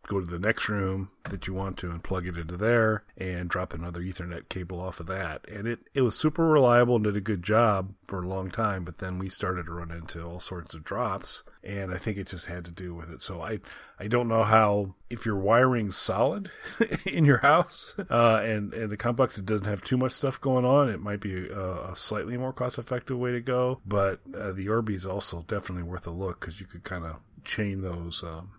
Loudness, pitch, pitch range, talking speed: -28 LUFS, 95 Hz, 90-115 Hz, 240 wpm